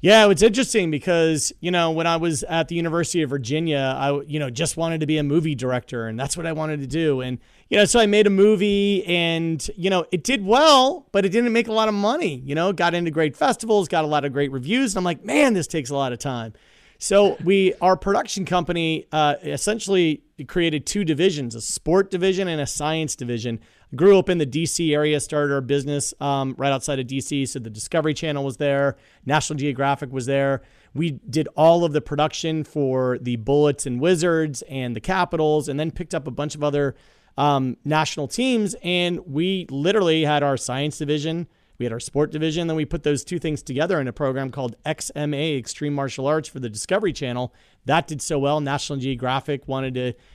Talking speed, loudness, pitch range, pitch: 215 wpm, -21 LUFS, 140-175 Hz, 155 Hz